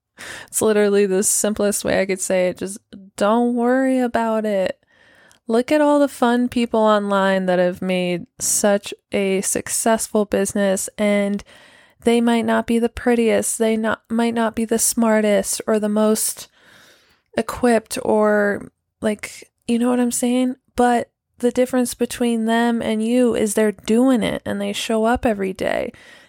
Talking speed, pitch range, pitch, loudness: 160 wpm, 205-240 Hz, 225 Hz, -19 LUFS